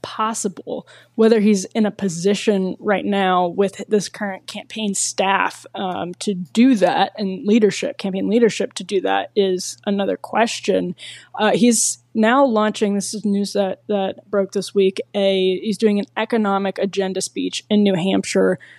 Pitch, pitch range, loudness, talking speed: 200 Hz, 190-215 Hz, -19 LUFS, 155 wpm